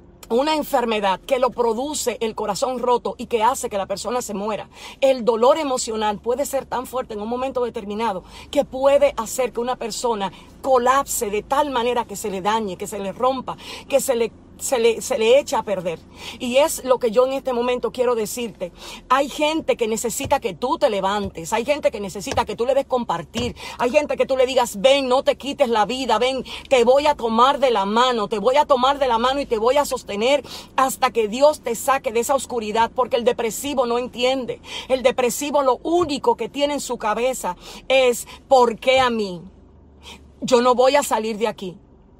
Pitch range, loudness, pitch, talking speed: 225-270 Hz, -20 LUFS, 250 Hz, 210 wpm